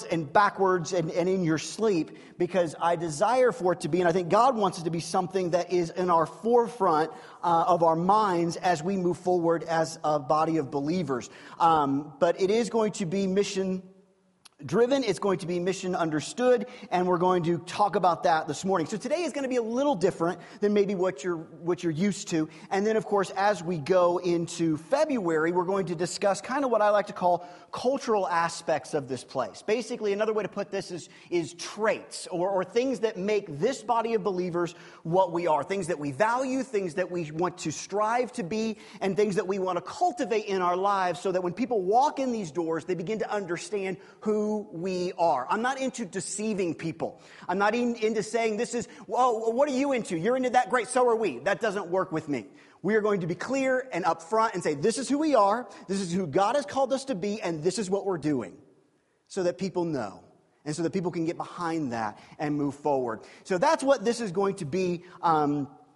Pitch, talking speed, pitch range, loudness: 190 Hz, 225 wpm, 170-220 Hz, -27 LUFS